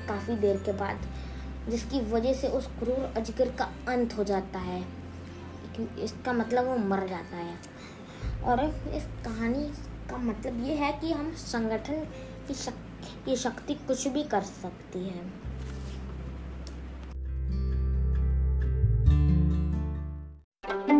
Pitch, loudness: 185 Hz, -31 LUFS